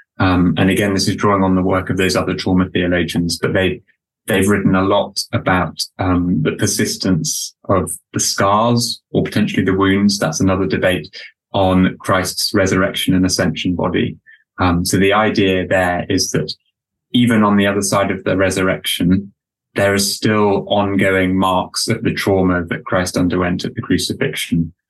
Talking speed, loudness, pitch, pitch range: 170 wpm, -16 LUFS, 95 Hz, 90-100 Hz